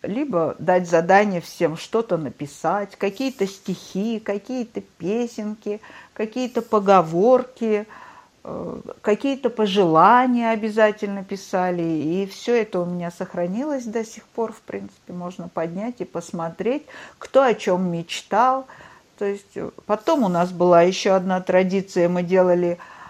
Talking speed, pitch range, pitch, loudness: 120 wpm, 180-225 Hz, 200 Hz, -21 LUFS